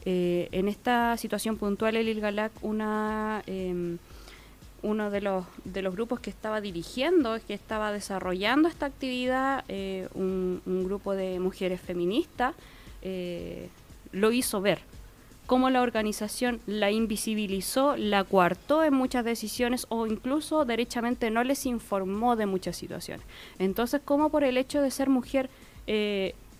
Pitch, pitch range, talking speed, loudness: 215 Hz, 190-245 Hz, 140 wpm, -29 LUFS